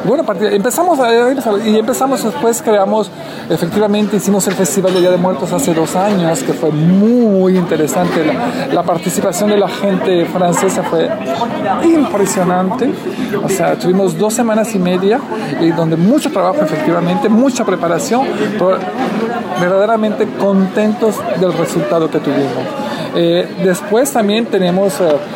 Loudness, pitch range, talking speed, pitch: -13 LUFS, 180-220 Hz, 135 wpm, 200 Hz